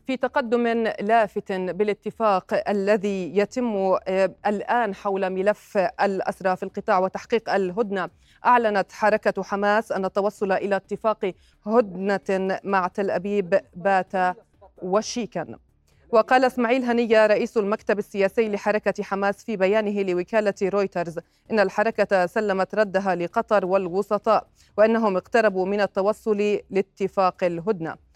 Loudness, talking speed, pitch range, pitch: -23 LUFS, 110 wpm, 190-215 Hz, 200 Hz